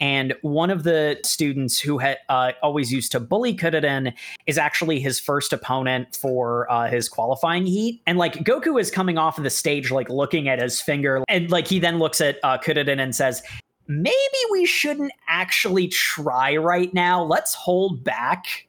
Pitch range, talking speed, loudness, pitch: 135-180 Hz, 185 wpm, -21 LUFS, 150 Hz